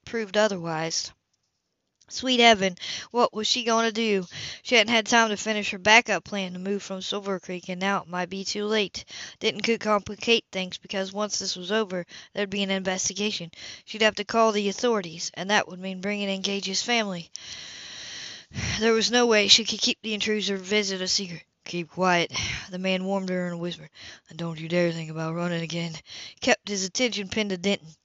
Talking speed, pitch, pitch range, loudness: 200 wpm, 200 Hz, 180-215 Hz, -25 LUFS